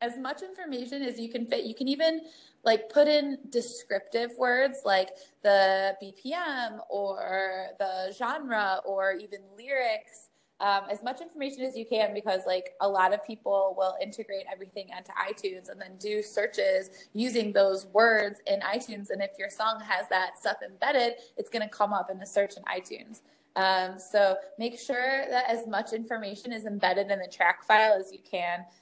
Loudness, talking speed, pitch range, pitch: -29 LUFS, 180 wpm, 195-245 Hz, 215 Hz